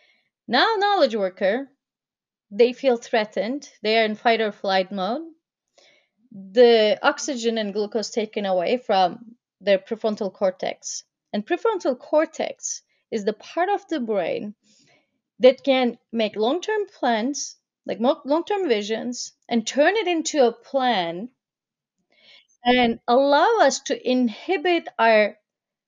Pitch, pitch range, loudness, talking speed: 240 Hz, 220-285 Hz, -22 LUFS, 125 wpm